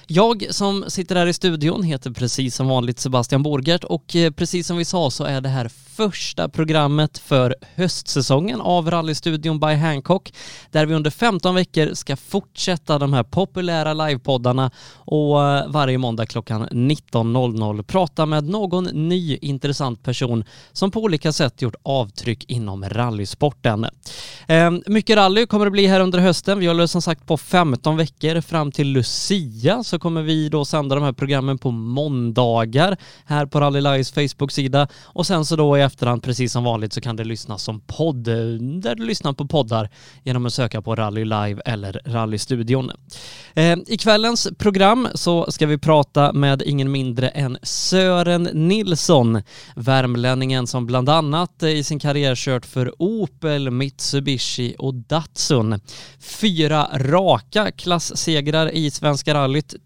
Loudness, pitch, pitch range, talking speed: -19 LUFS, 145 Hz, 130-170 Hz, 155 wpm